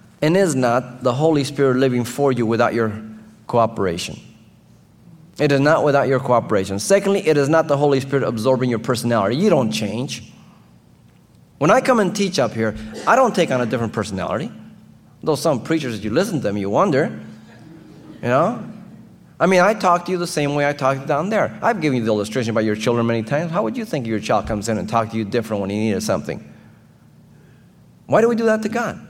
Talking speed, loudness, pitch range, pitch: 215 wpm, -19 LUFS, 110-155 Hz, 125 Hz